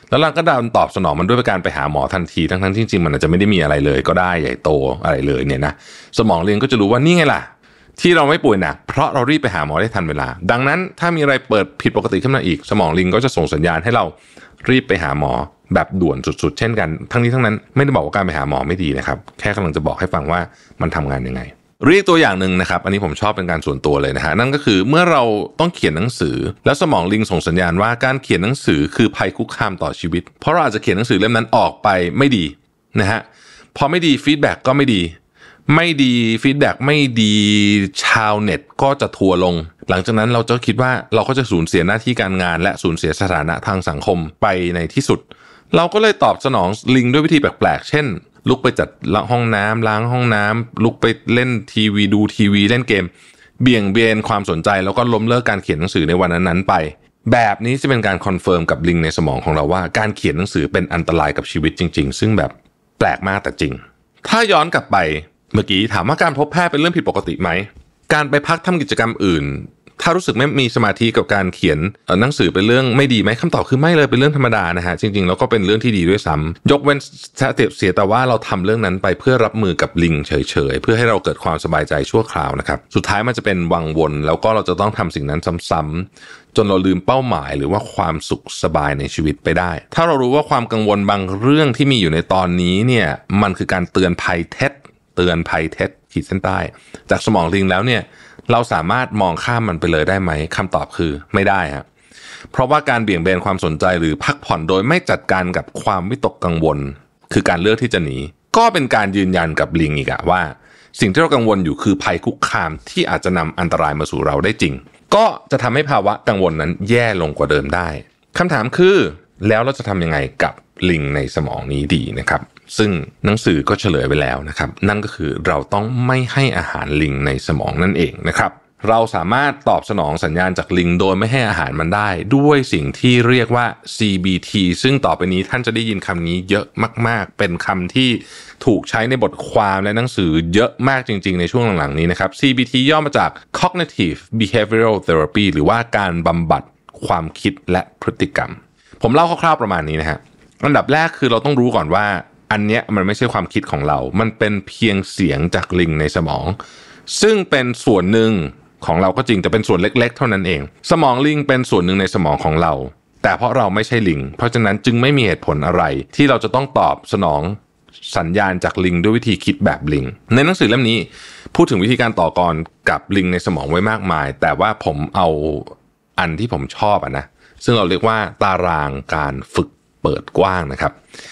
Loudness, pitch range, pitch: -16 LUFS, 85-120 Hz, 100 Hz